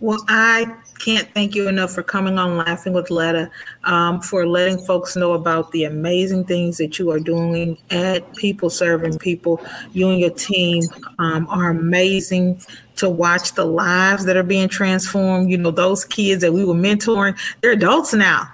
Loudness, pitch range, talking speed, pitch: -18 LUFS, 170-195 Hz, 180 wpm, 180 Hz